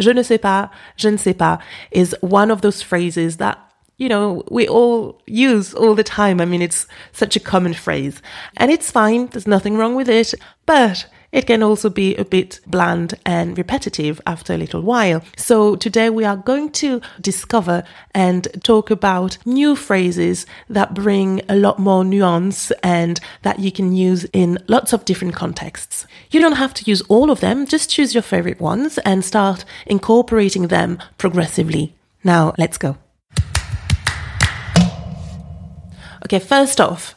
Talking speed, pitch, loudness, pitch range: 165 wpm, 200 Hz, -16 LUFS, 180-225 Hz